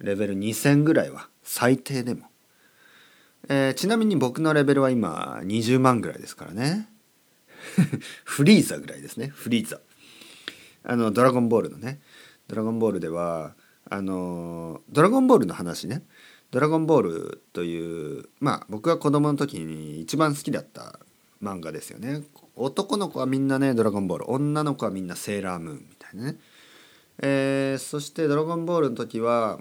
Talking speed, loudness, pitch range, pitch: 330 characters per minute, -24 LUFS, 105-145 Hz, 130 Hz